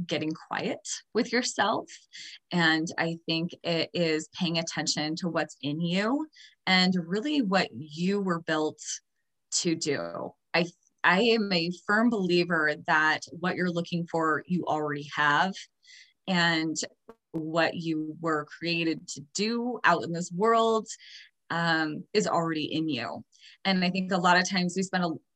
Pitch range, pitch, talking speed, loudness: 160-190 Hz, 170 Hz, 150 wpm, -28 LUFS